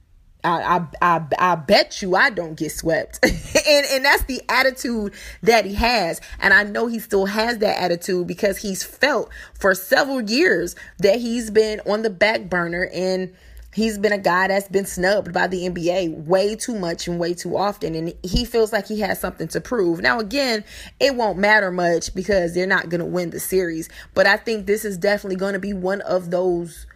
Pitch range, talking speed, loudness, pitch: 180-220 Hz, 205 wpm, -20 LUFS, 195 Hz